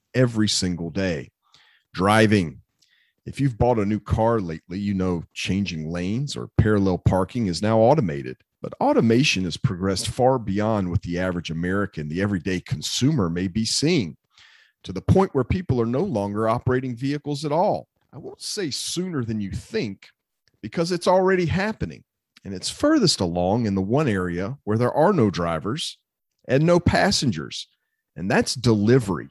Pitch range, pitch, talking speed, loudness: 95-130 Hz, 110 Hz, 160 wpm, -22 LUFS